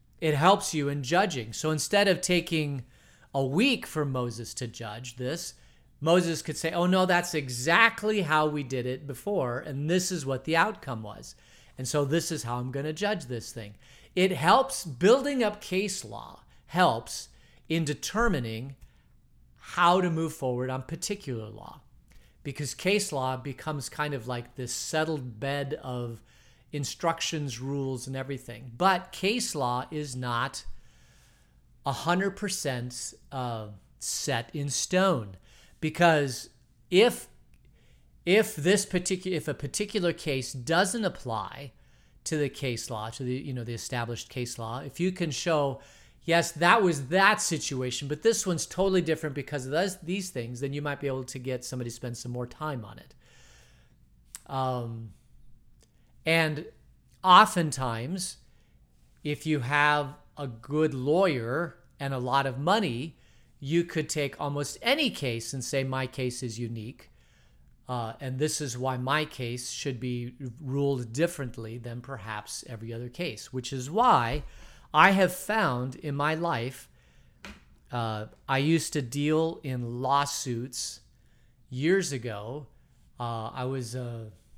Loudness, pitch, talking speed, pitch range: -28 LUFS, 140 Hz, 150 wpm, 125-165 Hz